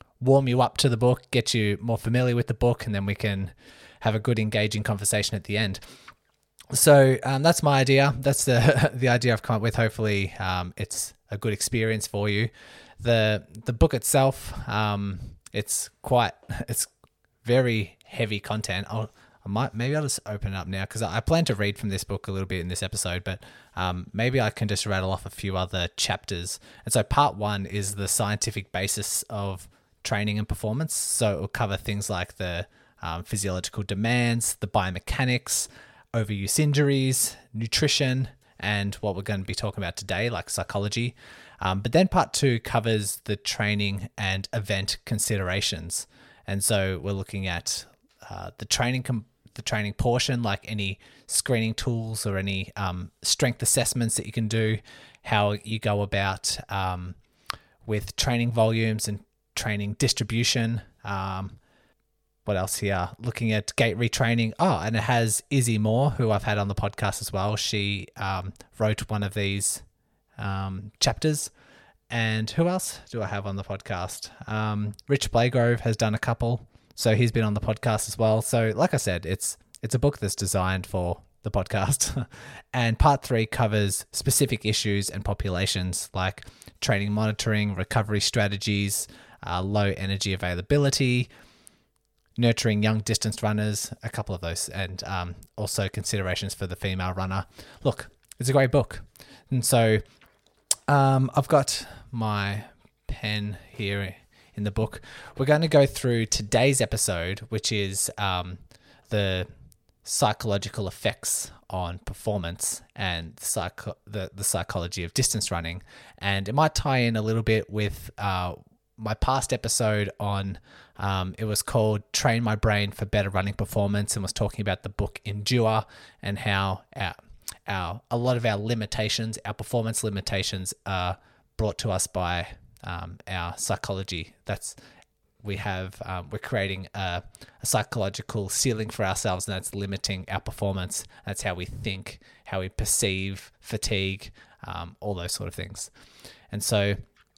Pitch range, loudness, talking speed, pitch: 100-115 Hz, -26 LUFS, 165 wpm, 105 Hz